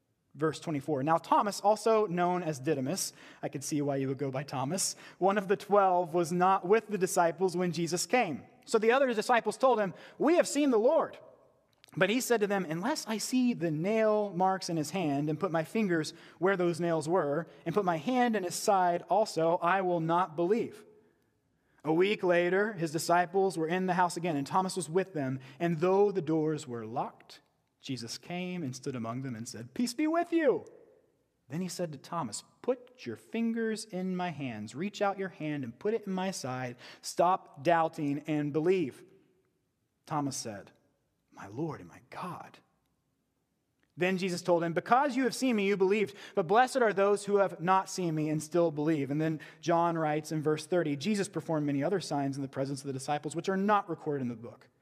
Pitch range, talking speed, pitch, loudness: 155-200 Hz, 205 wpm, 175 Hz, -31 LUFS